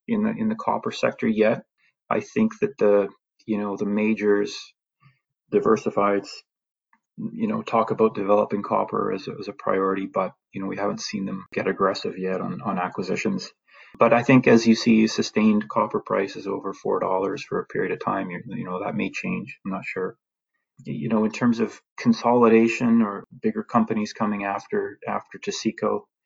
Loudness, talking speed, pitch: -24 LUFS, 180 wpm, 115 Hz